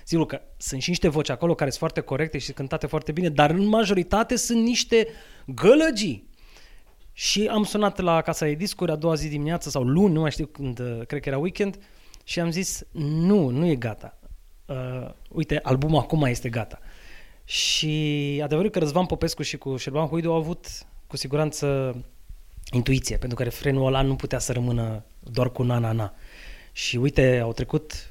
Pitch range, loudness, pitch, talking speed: 130-170 Hz, -24 LUFS, 150 Hz, 175 wpm